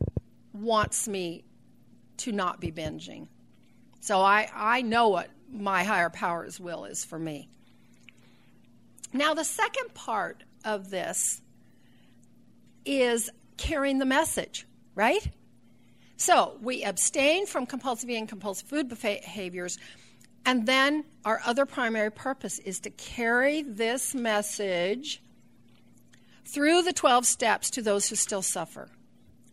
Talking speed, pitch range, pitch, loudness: 120 wpm, 195-270 Hz, 220 Hz, -27 LUFS